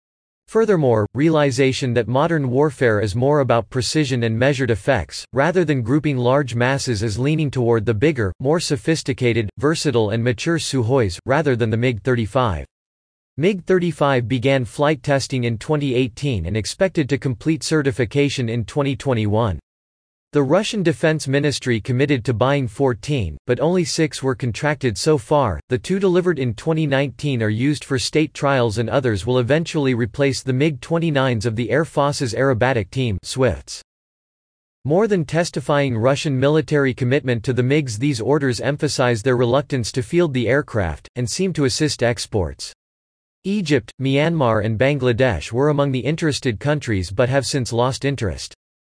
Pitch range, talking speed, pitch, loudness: 120-150 Hz, 150 wpm, 135 Hz, -19 LUFS